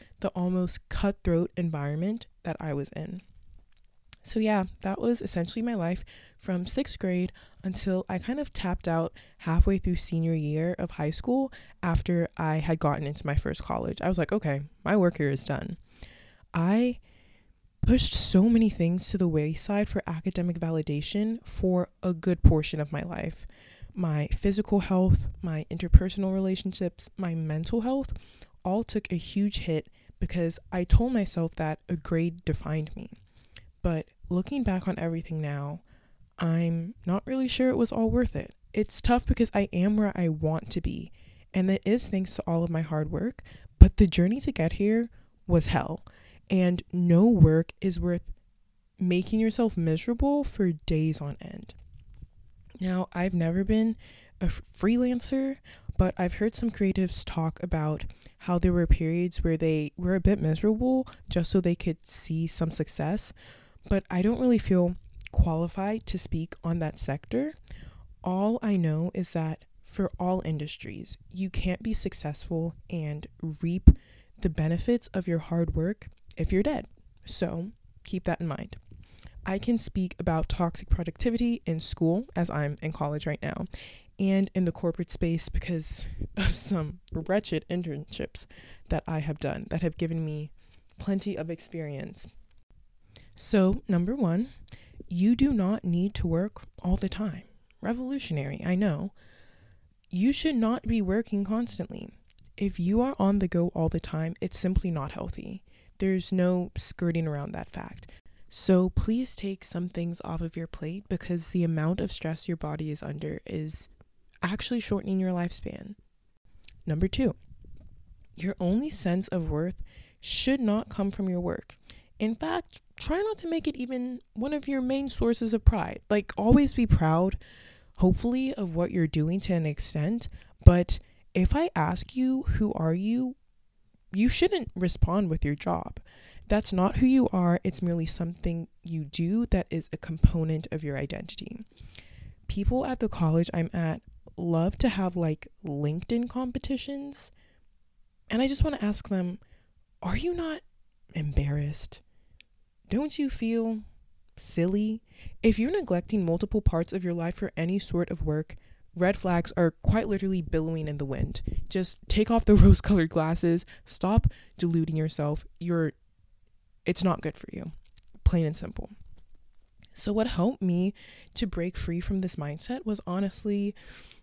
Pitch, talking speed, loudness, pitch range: 180 Hz, 160 wpm, -28 LUFS, 160-210 Hz